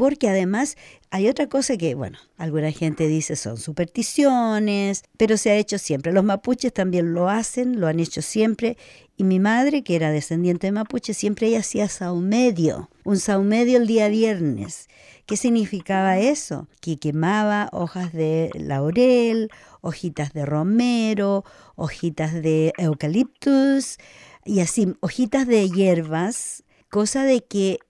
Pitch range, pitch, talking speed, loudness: 165-230 Hz, 200 Hz, 140 wpm, -21 LUFS